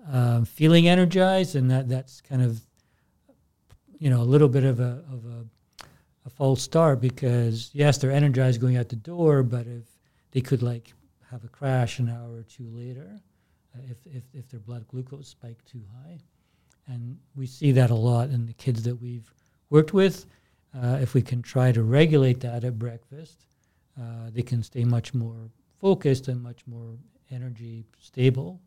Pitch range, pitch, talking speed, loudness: 120-140 Hz, 125 Hz, 180 wpm, -23 LUFS